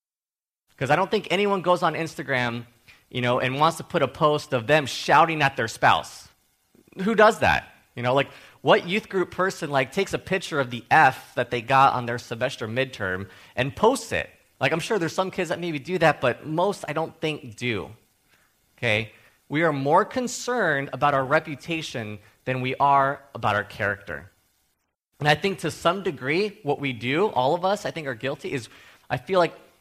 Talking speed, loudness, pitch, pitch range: 200 wpm, -24 LUFS, 140 Hz, 125-170 Hz